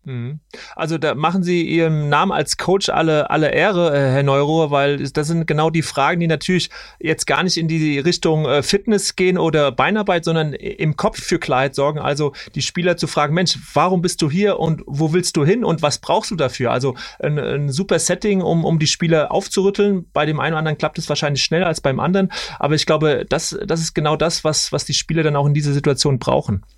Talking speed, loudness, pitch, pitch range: 215 wpm, -18 LUFS, 160 Hz, 145-175 Hz